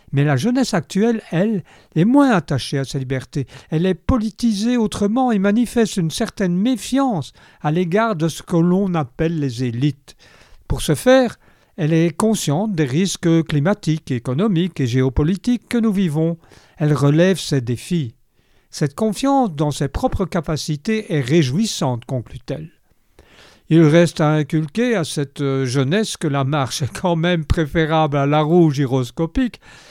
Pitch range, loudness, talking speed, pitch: 140-205 Hz, -18 LUFS, 150 wpm, 165 Hz